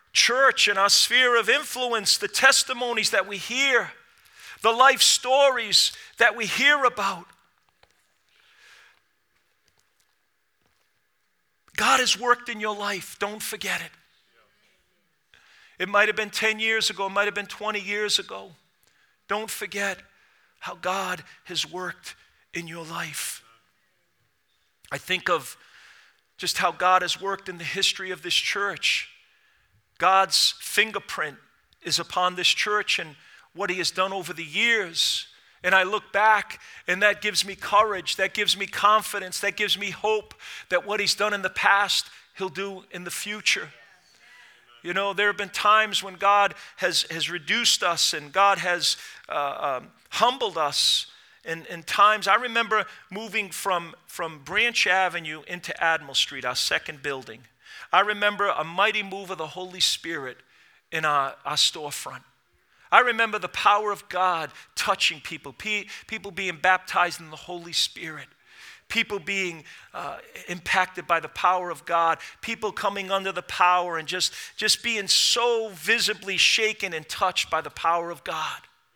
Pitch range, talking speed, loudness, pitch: 180-215 Hz, 150 wpm, -23 LUFS, 200 Hz